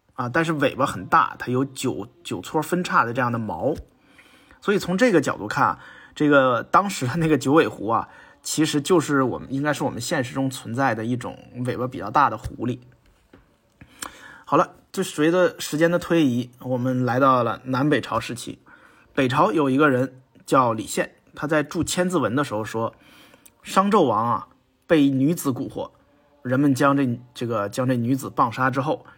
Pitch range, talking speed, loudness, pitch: 125-155 Hz, 260 characters per minute, -22 LUFS, 135 Hz